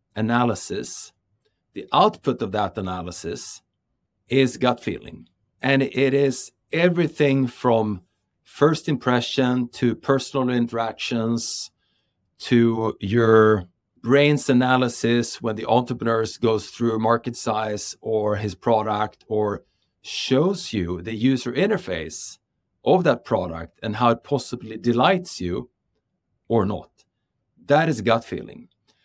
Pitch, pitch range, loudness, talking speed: 115 Hz, 110-130 Hz, -22 LUFS, 115 wpm